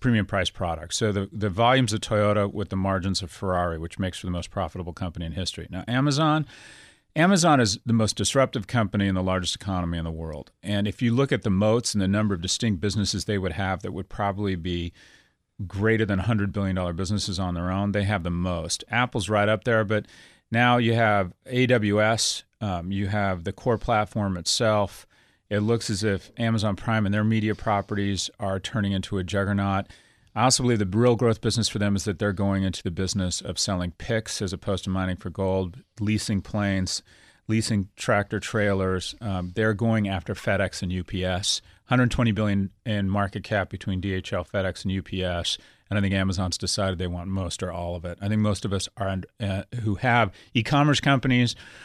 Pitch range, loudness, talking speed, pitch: 95-110 Hz, -25 LUFS, 200 wpm, 100 Hz